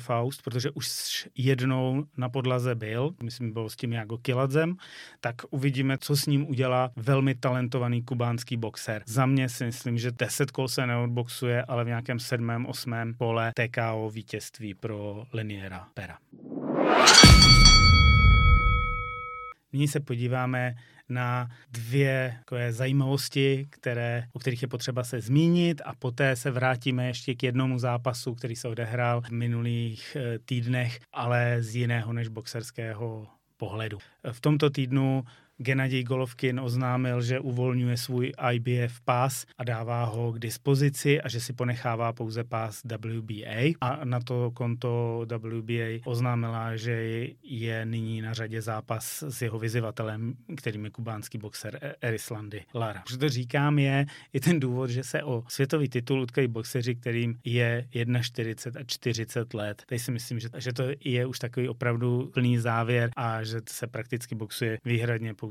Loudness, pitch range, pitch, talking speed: -27 LUFS, 115-130 Hz, 125 Hz, 145 wpm